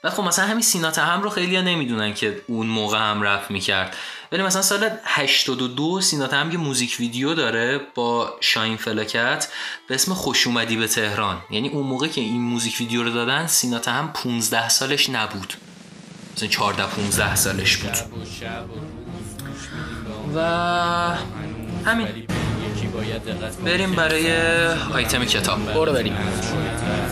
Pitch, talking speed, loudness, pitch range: 125 Hz, 135 wpm, -21 LUFS, 110-165 Hz